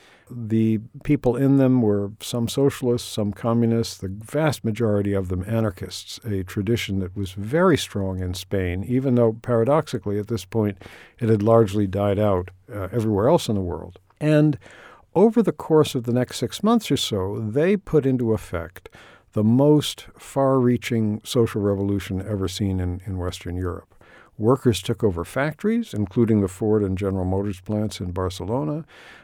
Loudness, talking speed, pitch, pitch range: -22 LUFS, 165 wpm, 110 Hz, 95-125 Hz